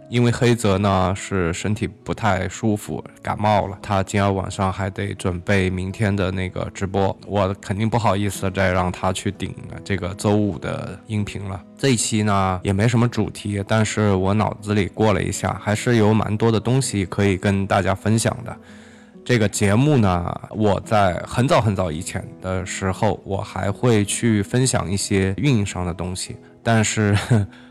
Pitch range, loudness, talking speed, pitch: 95-110 Hz, -21 LUFS, 260 characters per minute, 100 Hz